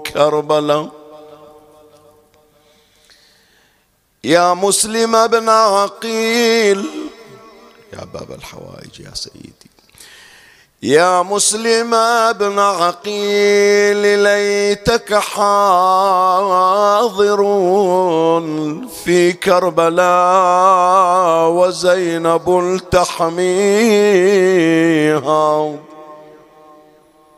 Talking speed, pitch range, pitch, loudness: 45 wpm, 155-205 Hz, 180 Hz, -13 LUFS